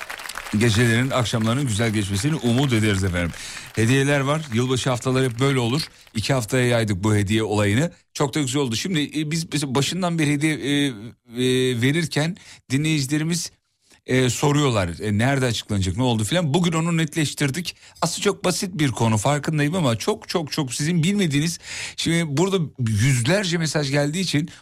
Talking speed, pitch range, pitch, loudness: 150 wpm, 120-160 Hz, 140 Hz, -22 LUFS